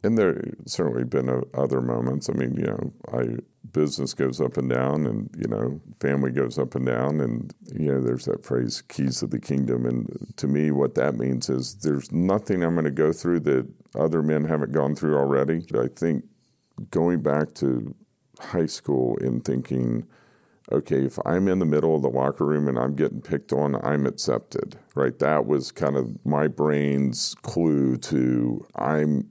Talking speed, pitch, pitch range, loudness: 190 wpm, 70 Hz, 65-75 Hz, -25 LUFS